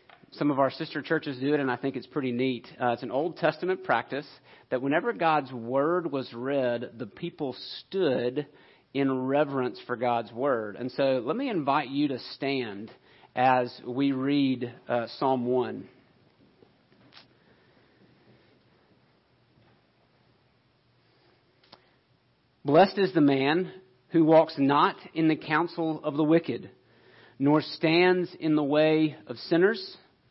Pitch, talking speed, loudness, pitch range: 140 Hz, 135 wpm, -27 LUFS, 125-155 Hz